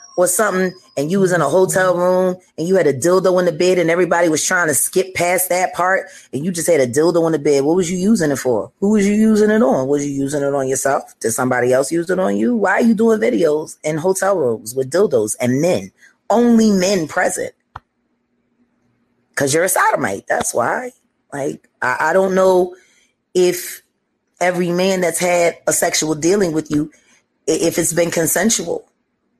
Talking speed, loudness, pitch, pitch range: 205 wpm, -16 LUFS, 180 Hz, 155-190 Hz